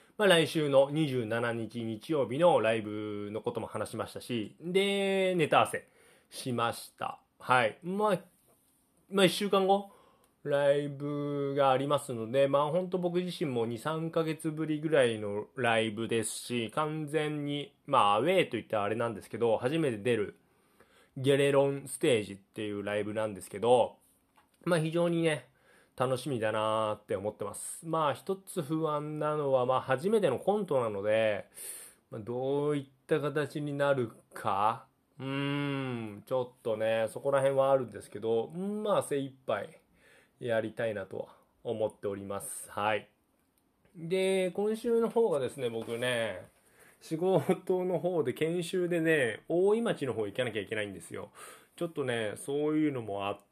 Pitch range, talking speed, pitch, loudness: 115-170 Hz, 300 characters per minute, 140 Hz, -31 LUFS